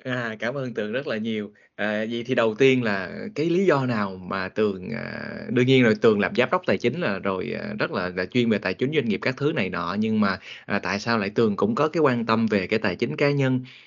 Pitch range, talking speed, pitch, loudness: 105-135 Hz, 275 wpm, 120 Hz, -24 LUFS